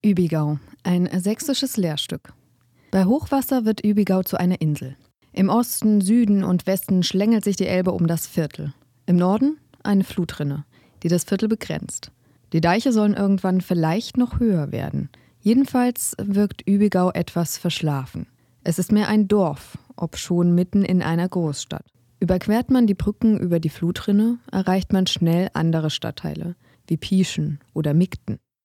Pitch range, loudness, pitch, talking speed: 165-210 Hz, -21 LUFS, 185 Hz, 145 wpm